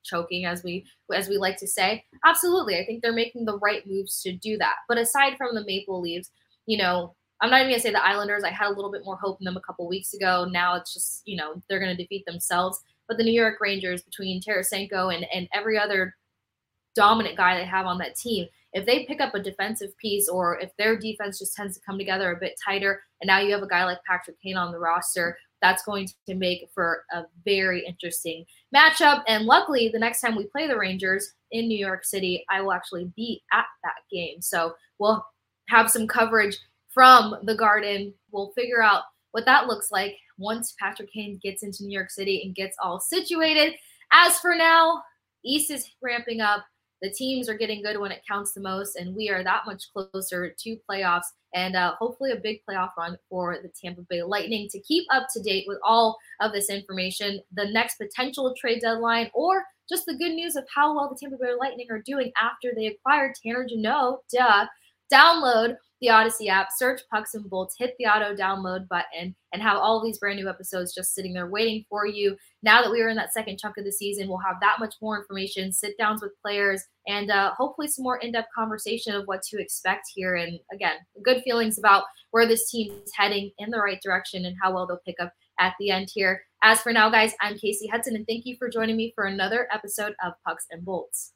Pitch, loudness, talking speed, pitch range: 205 Hz, -24 LUFS, 220 wpm, 185-230 Hz